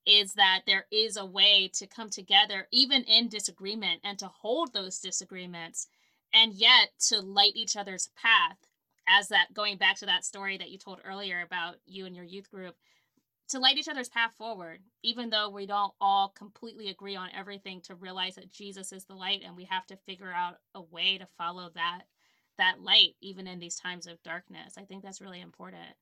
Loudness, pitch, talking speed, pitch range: -26 LUFS, 195 Hz, 200 wpm, 185-210 Hz